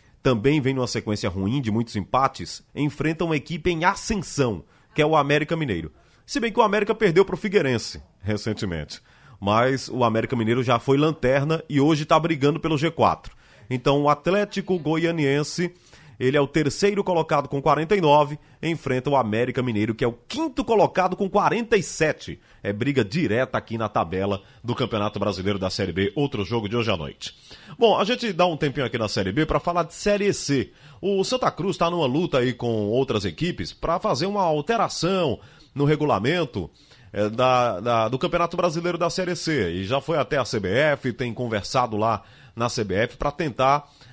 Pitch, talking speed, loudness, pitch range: 140 Hz, 180 wpm, -23 LUFS, 115-165 Hz